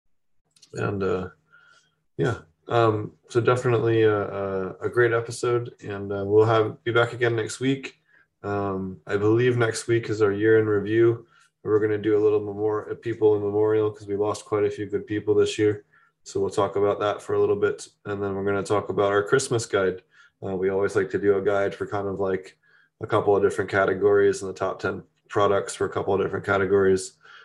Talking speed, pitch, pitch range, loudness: 215 wpm, 105 Hz, 100-120 Hz, -24 LUFS